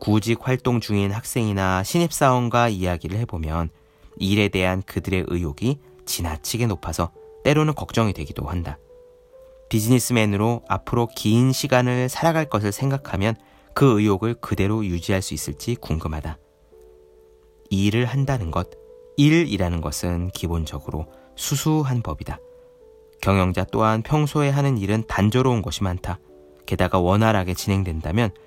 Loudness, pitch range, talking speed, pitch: -22 LUFS, 90-130 Hz, 310 characters per minute, 105 Hz